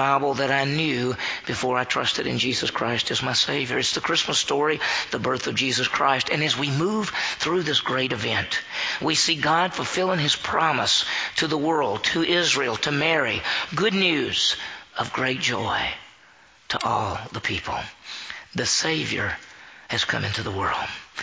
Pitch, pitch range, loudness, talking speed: 140 Hz, 125-165 Hz, -23 LUFS, 165 wpm